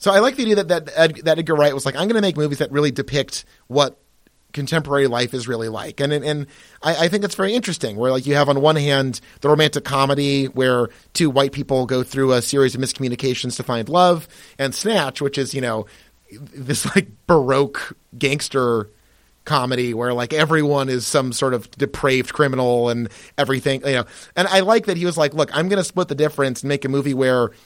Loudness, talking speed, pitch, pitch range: -19 LUFS, 220 wpm, 140 Hz, 130-155 Hz